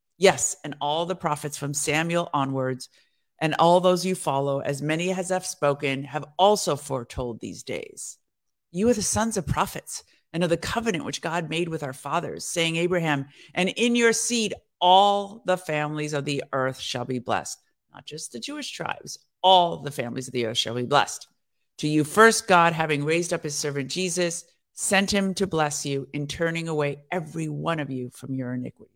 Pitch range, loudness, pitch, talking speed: 140-185 Hz, -24 LUFS, 160 Hz, 195 wpm